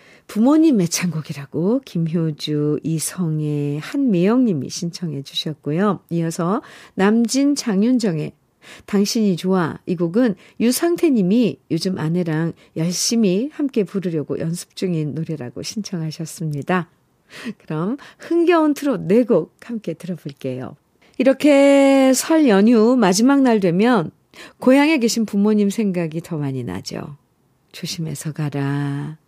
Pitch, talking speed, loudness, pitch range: 185 Hz, 265 characters per minute, -19 LUFS, 160-235 Hz